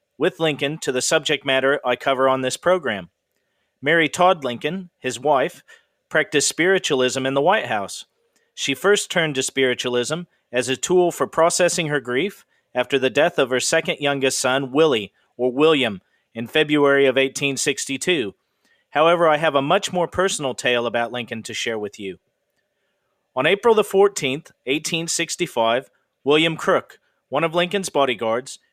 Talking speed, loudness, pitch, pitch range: 160 wpm, -20 LUFS, 145 Hz, 130-175 Hz